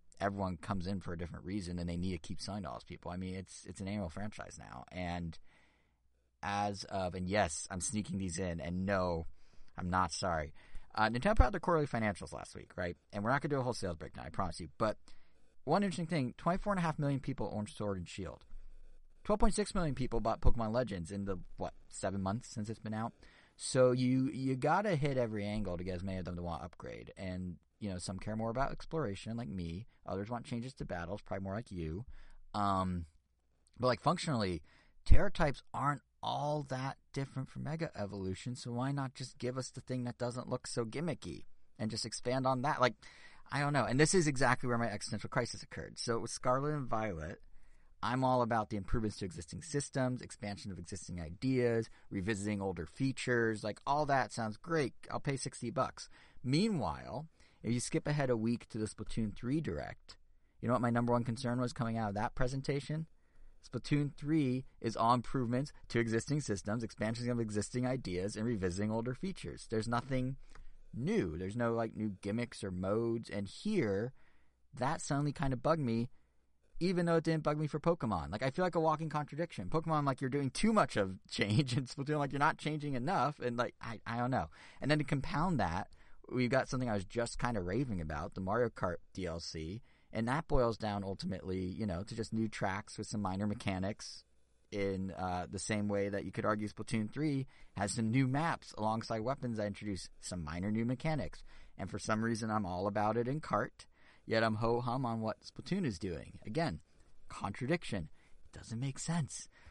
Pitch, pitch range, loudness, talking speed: 115 Hz, 95-130 Hz, -37 LUFS, 205 wpm